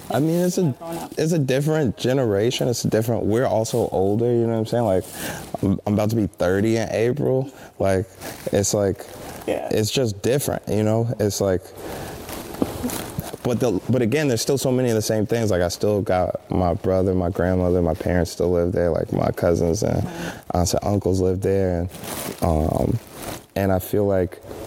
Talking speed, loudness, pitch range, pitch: 185 wpm, -22 LUFS, 90-120 Hz, 105 Hz